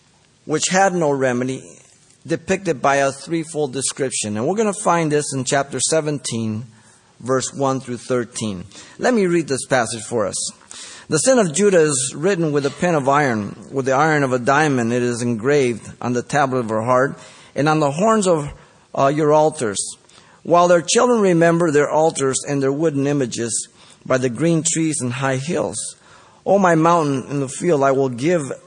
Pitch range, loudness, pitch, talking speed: 130-165 Hz, -18 LUFS, 140 Hz, 190 wpm